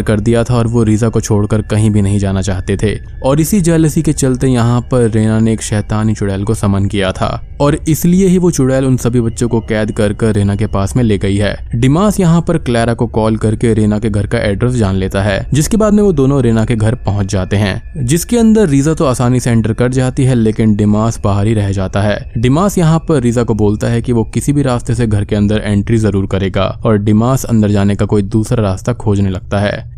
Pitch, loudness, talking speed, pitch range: 115 Hz, -12 LUFS, 245 wpm, 105-130 Hz